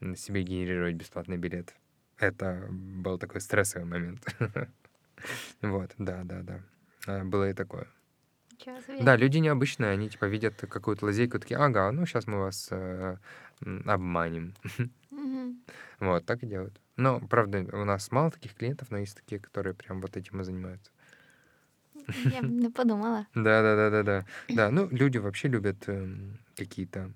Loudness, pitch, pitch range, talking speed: -30 LUFS, 100 Hz, 95-125 Hz, 140 wpm